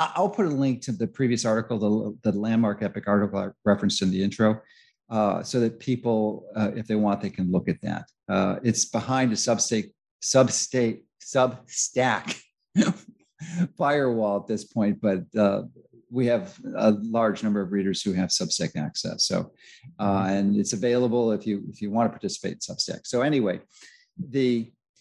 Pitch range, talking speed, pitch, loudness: 105-130 Hz, 175 wpm, 115 Hz, -25 LUFS